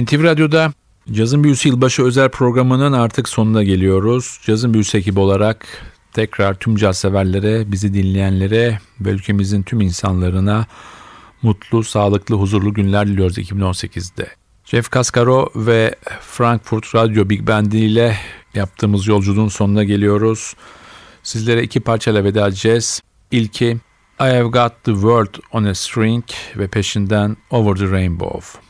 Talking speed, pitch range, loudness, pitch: 130 wpm, 100-115 Hz, -16 LUFS, 110 Hz